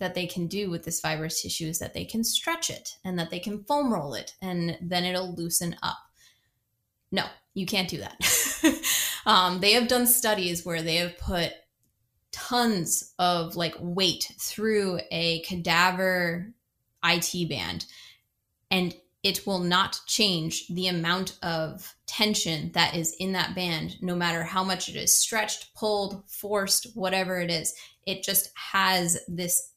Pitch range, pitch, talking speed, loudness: 170-195 Hz, 180 Hz, 160 wpm, -26 LUFS